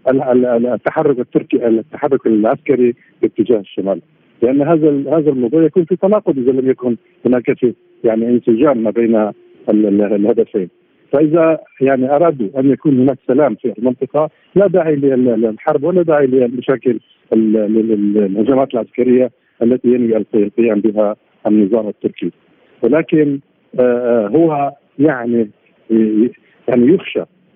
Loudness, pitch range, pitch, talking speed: -14 LUFS, 115-150 Hz, 125 Hz, 110 wpm